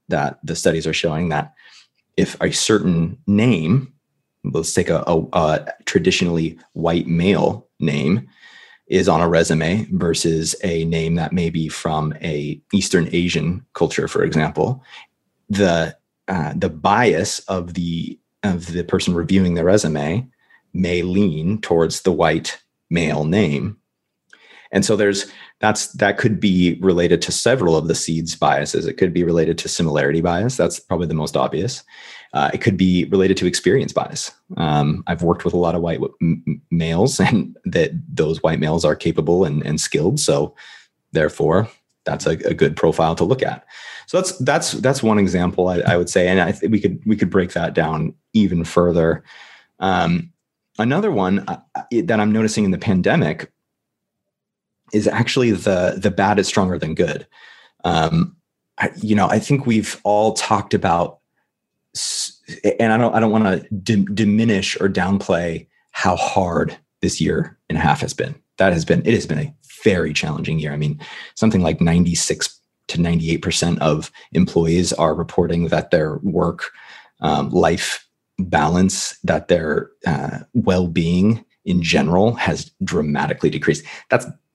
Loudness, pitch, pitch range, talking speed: -19 LUFS, 90 Hz, 85-105 Hz, 165 wpm